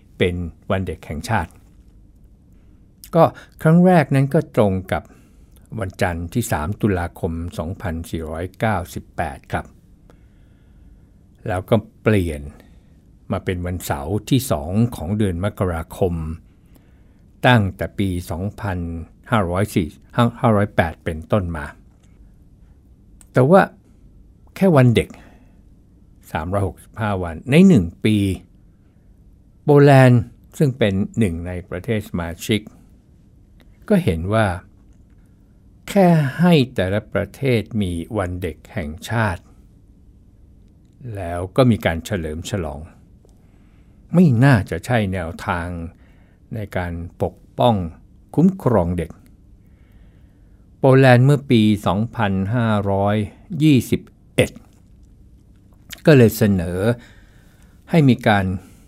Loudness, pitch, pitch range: -19 LUFS, 100 Hz, 90-110 Hz